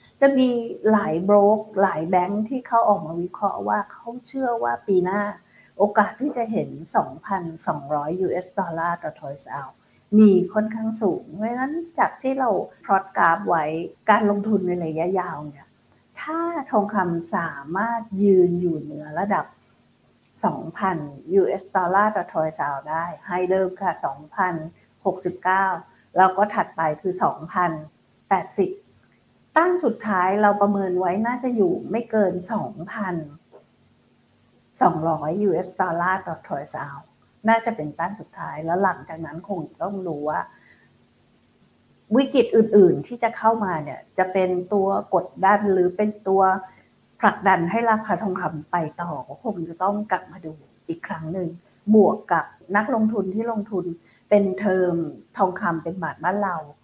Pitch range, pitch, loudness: 170-210 Hz, 190 Hz, -22 LUFS